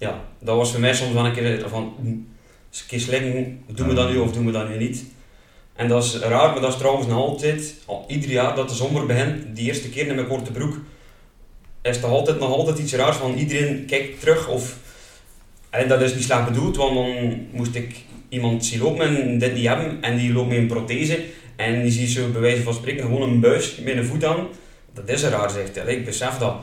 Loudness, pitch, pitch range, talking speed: -22 LUFS, 125 Hz, 120-135 Hz, 240 wpm